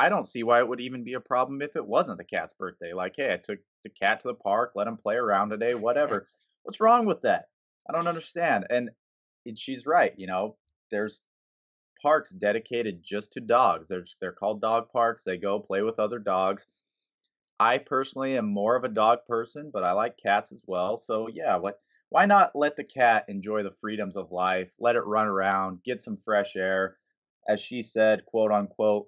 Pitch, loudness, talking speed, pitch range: 110 Hz, -27 LUFS, 210 wpm, 100-125 Hz